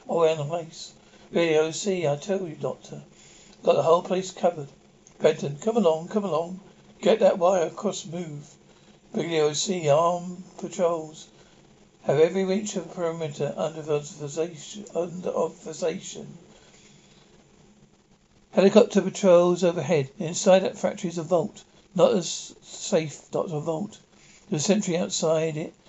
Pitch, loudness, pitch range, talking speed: 175 Hz, -25 LUFS, 160-190 Hz, 130 wpm